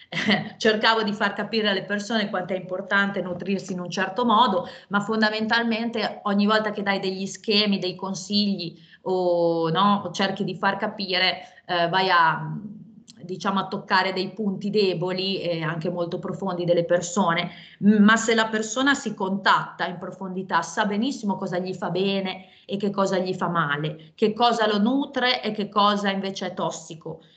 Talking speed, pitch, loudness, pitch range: 165 wpm, 195 Hz, -23 LUFS, 180-210 Hz